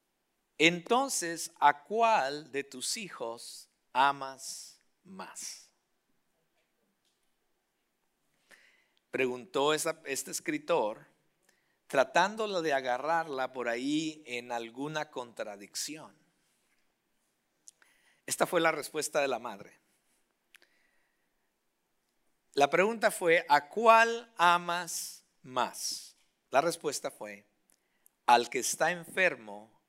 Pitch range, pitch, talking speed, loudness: 130-180 Hz, 155 Hz, 80 wpm, -30 LUFS